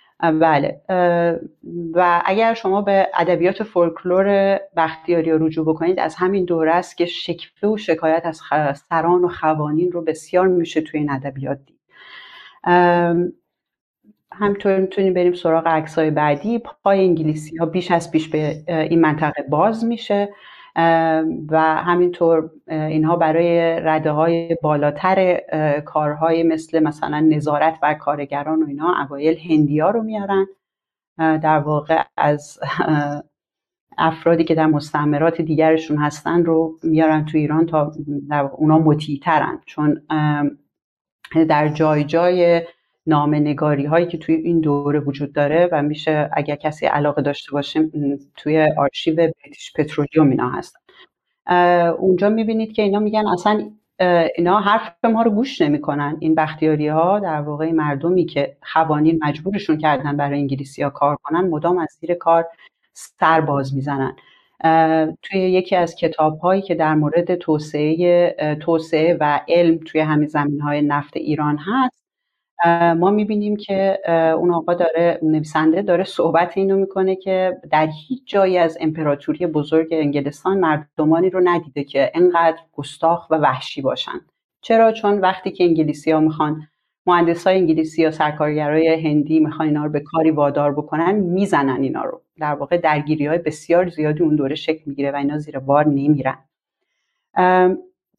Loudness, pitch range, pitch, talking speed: -18 LUFS, 150-175 Hz, 160 Hz, 140 wpm